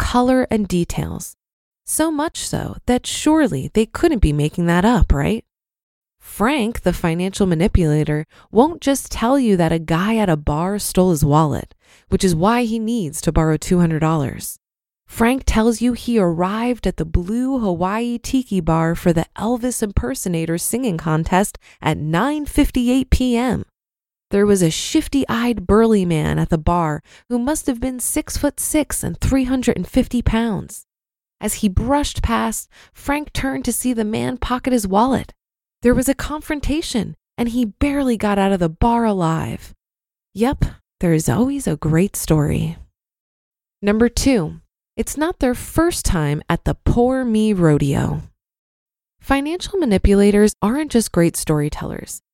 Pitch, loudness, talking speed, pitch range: 220 Hz, -19 LUFS, 155 wpm, 170-250 Hz